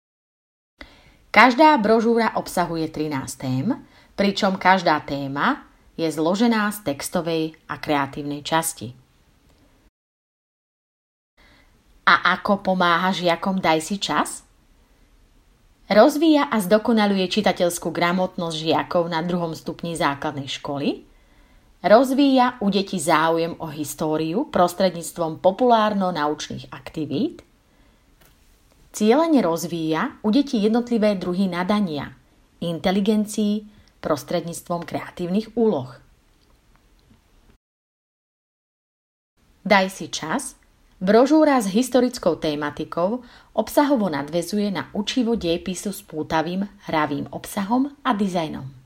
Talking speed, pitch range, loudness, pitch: 85 wpm, 155-215 Hz, -21 LUFS, 180 Hz